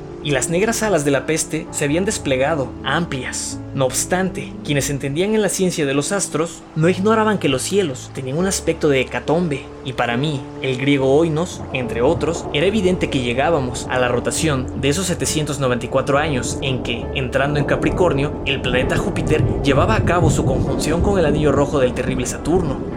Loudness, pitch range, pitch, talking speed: -19 LUFS, 135-170 Hz, 150 Hz, 185 wpm